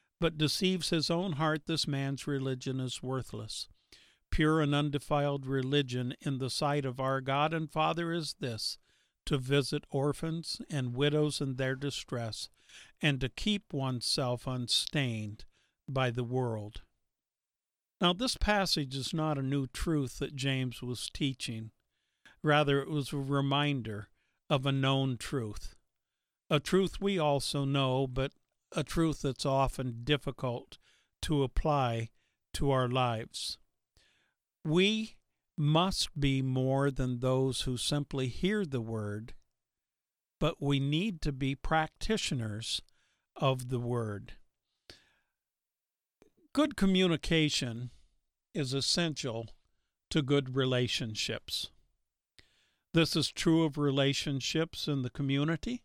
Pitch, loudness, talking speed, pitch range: 140 Hz, -32 LUFS, 120 wpm, 125-155 Hz